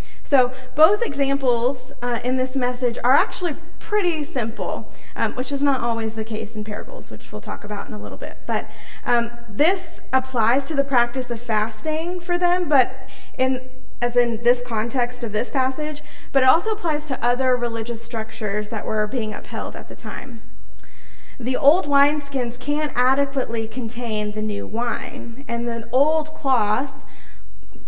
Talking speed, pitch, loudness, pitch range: 165 wpm, 255 Hz, -23 LUFS, 235-280 Hz